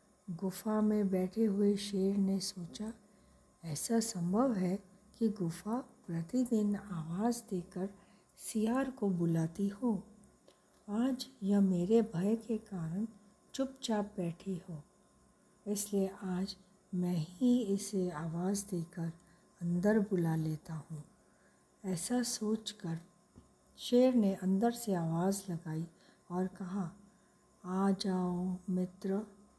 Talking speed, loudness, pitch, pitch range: 105 wpm, -35 LUFS, 195 Hz, 180-215 Hz